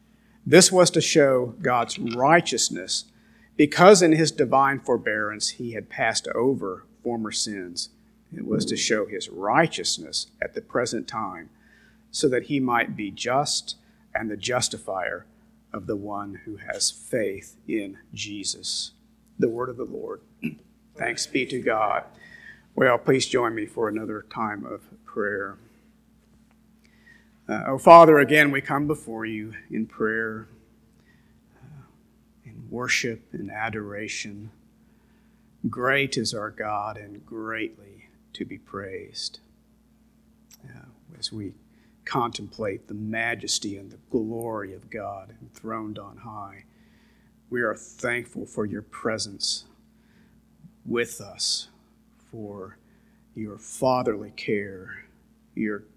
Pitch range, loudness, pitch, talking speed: 105-145 Hz, -24 LUFS, 115 Hz, 120 wpm